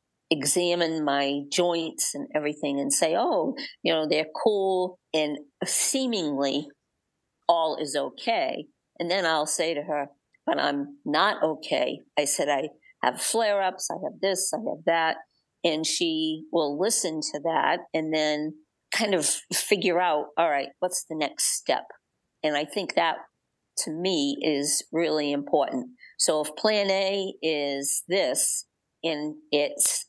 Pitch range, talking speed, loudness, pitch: 150-185 Hz, 150 wpm, -26 LUFS, 160 Hz